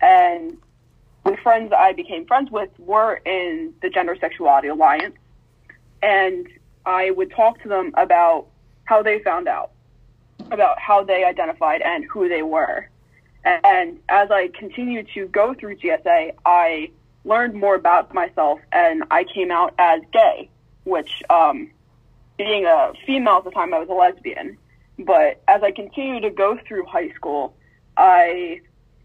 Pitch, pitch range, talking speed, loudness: 205 Hz, 180-295 Hz, 155 wpm, -18 LUFS